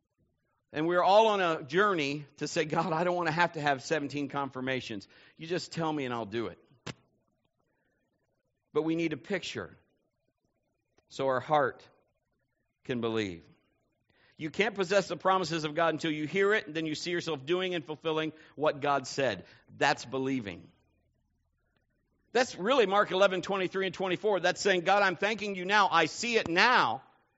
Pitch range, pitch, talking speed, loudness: 130-185 Hz, 155 Hz, 170 wpm, -29 LUFS